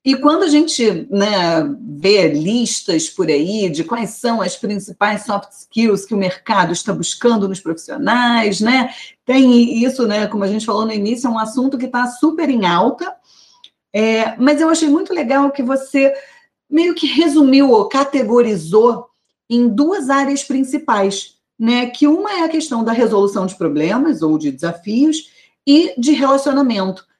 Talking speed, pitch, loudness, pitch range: 165 wpm, 240 Hz, -15 LUFS, 205-285 Hz